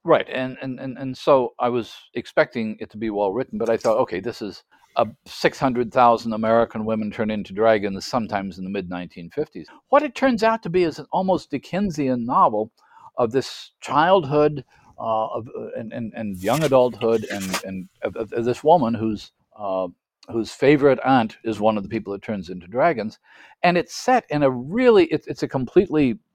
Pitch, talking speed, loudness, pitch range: 120 Hz, 195 wpm, -22 LUFS, 110-150 Hz